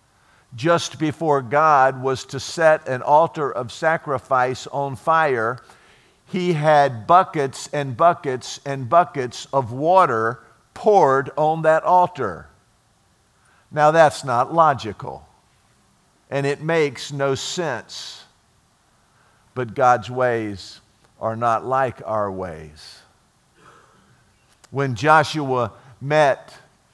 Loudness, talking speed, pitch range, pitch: -19 LUFS, 100 wpm, 120-155 Hz, 135 Hz